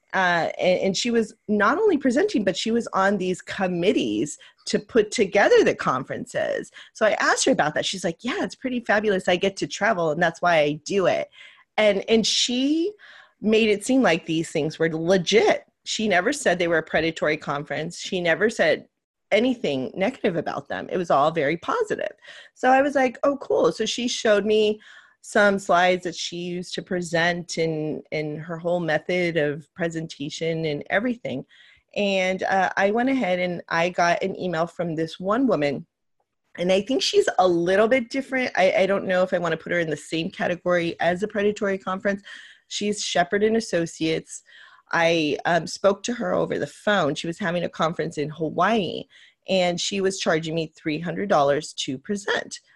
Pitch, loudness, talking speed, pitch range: 185 Hz, -23 LUFS, 190 wpm, 165-220 Hz